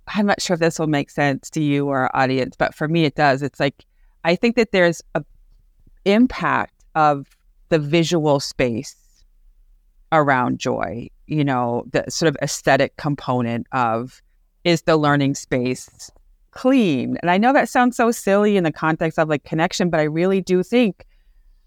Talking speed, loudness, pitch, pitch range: 175 wpm, -19 LUFS, 150 Hz, 125-175 Hz